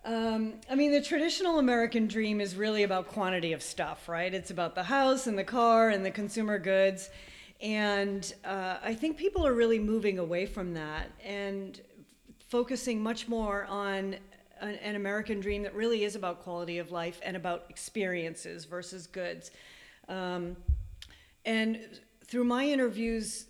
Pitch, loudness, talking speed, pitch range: 205 Hz, -31 LUFS, 160 wpm, 185-225 Hz